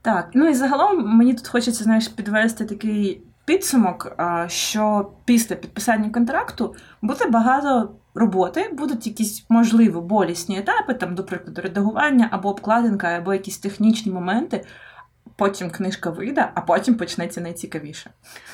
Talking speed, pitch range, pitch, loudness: 130 wpm, 190-235 Hz, 215 Hz, -20 LUFS